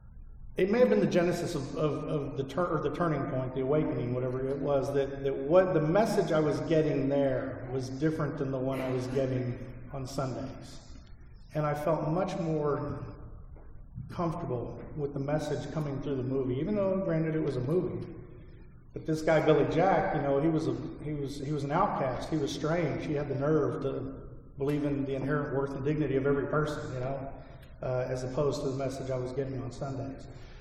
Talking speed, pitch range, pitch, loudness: 210 wpm, 135-155 Hz, 140 Hz, -31 LUFS